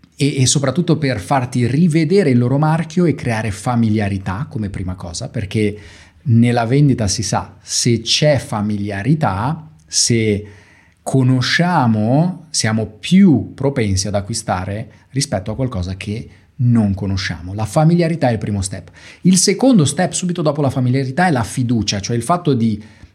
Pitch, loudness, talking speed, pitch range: 120 Hz, -16 LUFS, 145 wpm, 105-145 Hz